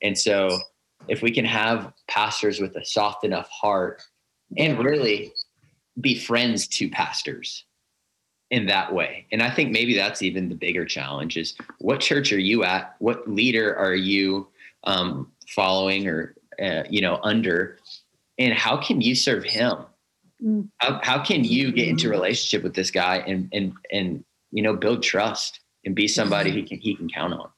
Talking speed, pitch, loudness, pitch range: 170 wpm, 100 Hz, -23 LUFS, 95-120 Hz